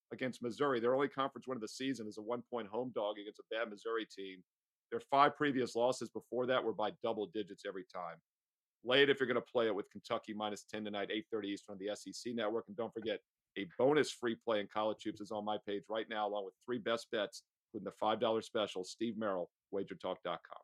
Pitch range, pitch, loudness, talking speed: 105-120 Hz, 110 Hz, -38 LUFS, 230 wpm